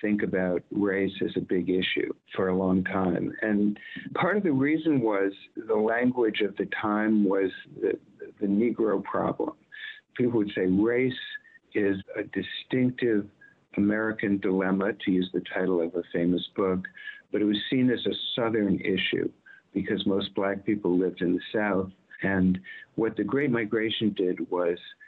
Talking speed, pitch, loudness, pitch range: 160 wpm, 105 Hz, -27 LUFS, 95-125 Hz